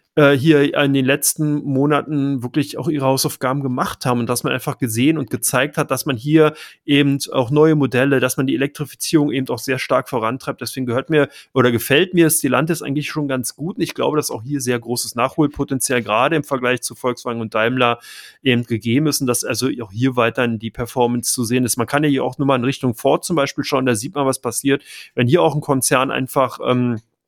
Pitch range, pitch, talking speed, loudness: 125-145 Hz, 135 Hz, 225 wpm, -18 LUFS